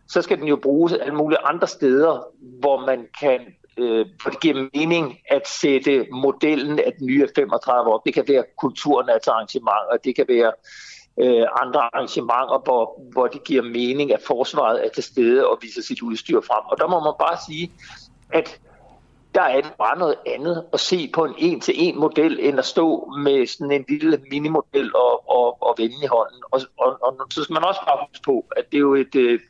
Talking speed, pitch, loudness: 205 wpm, 150 Hz, -20 LUFS